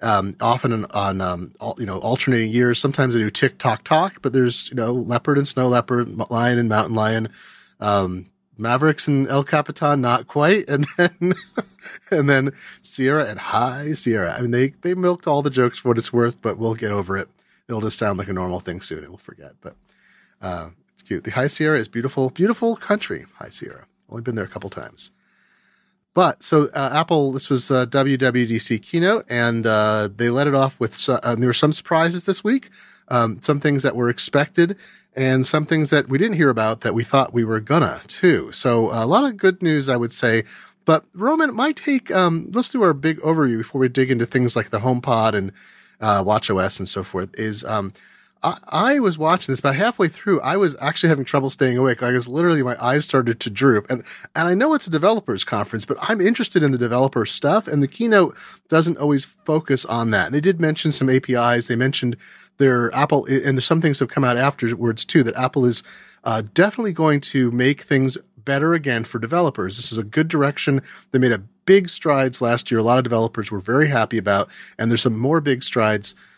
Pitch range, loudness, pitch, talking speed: 115-155 Hz, -19 LUFS, 130 Hz, 220 wpm